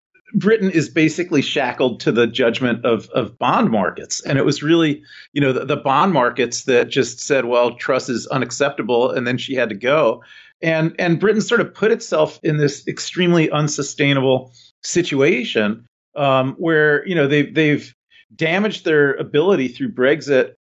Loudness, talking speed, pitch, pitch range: -18 LUFS, 165 wpm, 155 Hz, 140-175 Hz